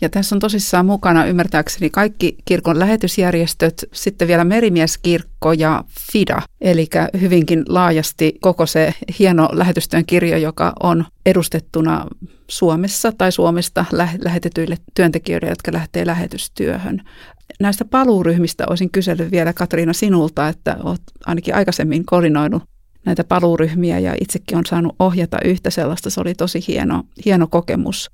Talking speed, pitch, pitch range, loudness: 130 wpm, 175 Hz, 165-185 Hz, -16 LUFS